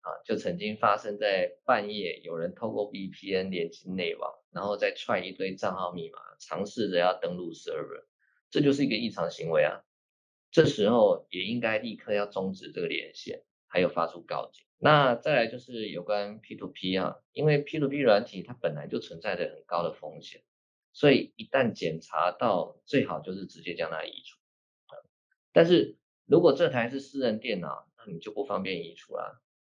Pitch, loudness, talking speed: 210 Hz, -29 LUFS, 285 characters per minute